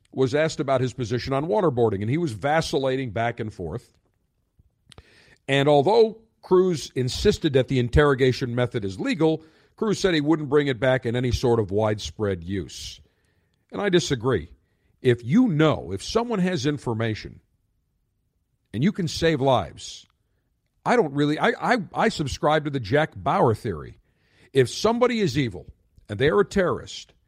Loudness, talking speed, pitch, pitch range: -23 LUFS, 160 wpm, 135 Hz, 110-160 Hz